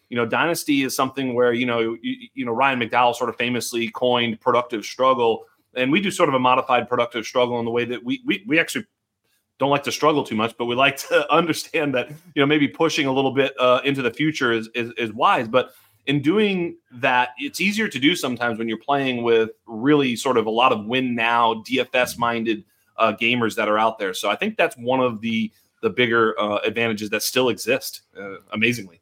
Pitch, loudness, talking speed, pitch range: 125 Hz, -21 LUFS, 225 wpm, 115-145 Hz